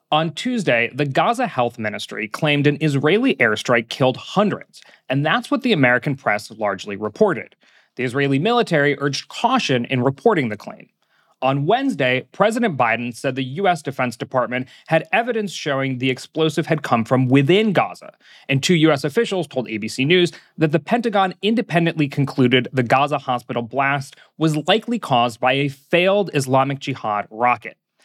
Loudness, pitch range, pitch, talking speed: -19 LUFS, 130-170 Hz, 140 Hz, 155 wpm